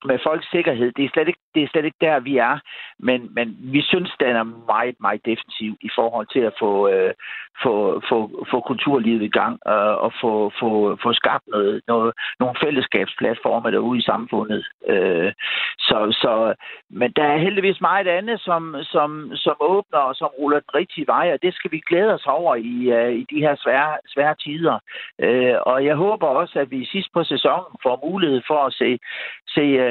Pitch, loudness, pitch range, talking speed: 150 Hz, -20 LUFS, 125-175 Hz, 200 wpm